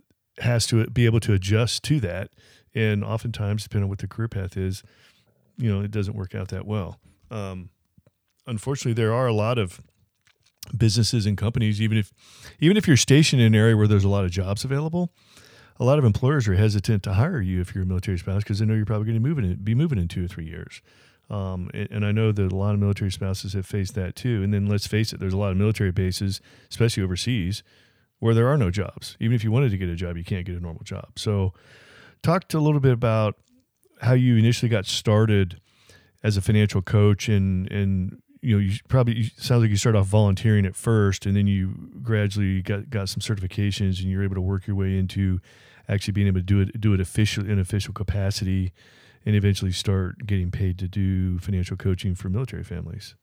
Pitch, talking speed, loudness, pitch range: 105 Hz, 220 wpm, -23 LUFS, 95-115 Hz